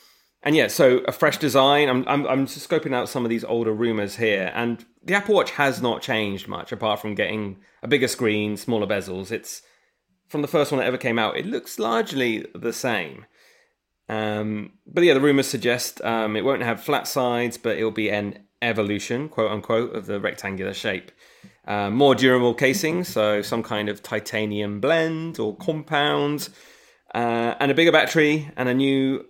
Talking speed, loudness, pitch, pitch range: 185 wpm, -22 LUFS, 120 Hz, 105-140 Hz